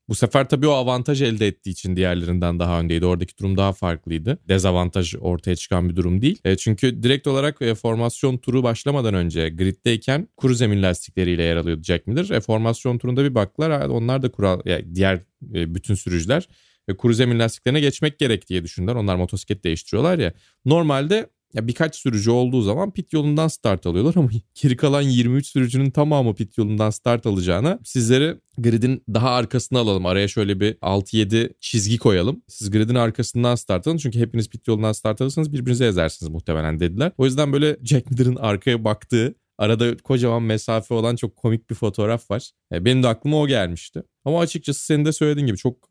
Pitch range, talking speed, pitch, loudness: 95-130 Hz, 180 wpm, 115 Hz, -21 LUFS